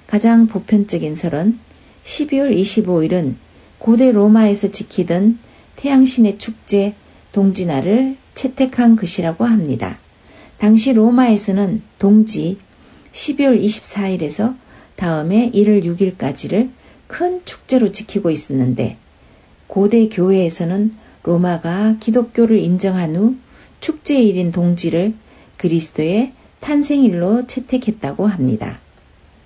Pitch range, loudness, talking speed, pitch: 175-230 Hz, -16 LUFS, 230 characters per minute, 205 Hz